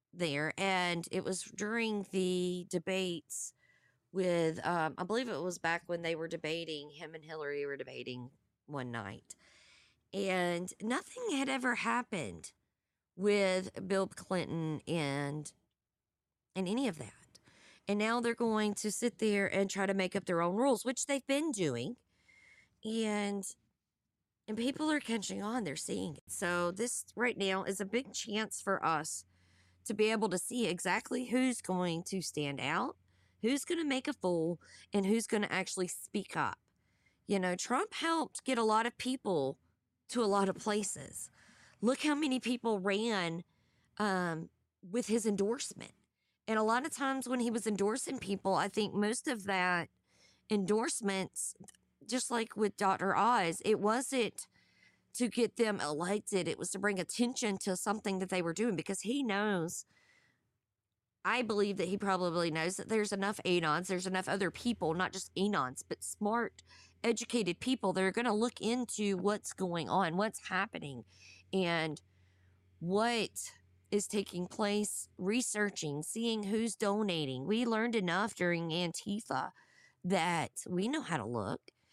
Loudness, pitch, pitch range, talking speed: -35 LUFS, 200 Hz, 175-225 Hz, 160 wpm